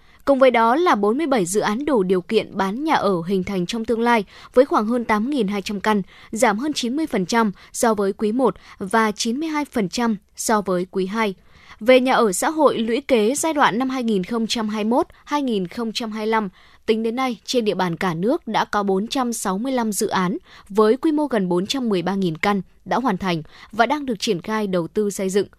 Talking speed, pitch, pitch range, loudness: 185 wpm, 220 Hz, 200-250 Hz, -20 LUFS